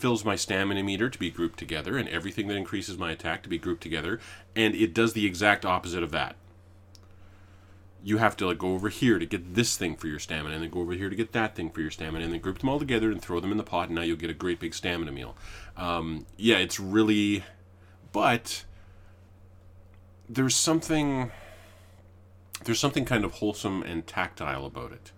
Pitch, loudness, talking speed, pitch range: 95 Hz, -28 LUFS, 210 wpm, 90-110 Hz